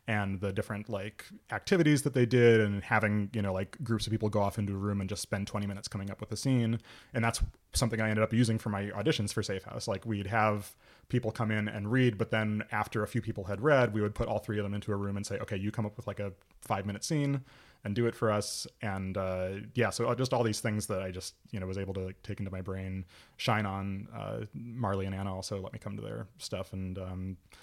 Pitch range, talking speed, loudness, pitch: 100-115 Hz, 265 wpm, -32 LUFS, 105 Hz